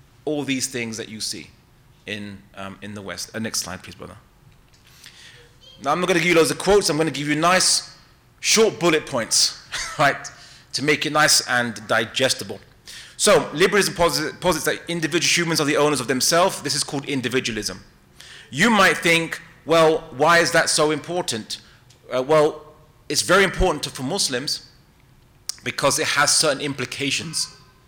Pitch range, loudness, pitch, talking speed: 125-165 Hz, -20 LUFS, 145 Hz, 170 wpm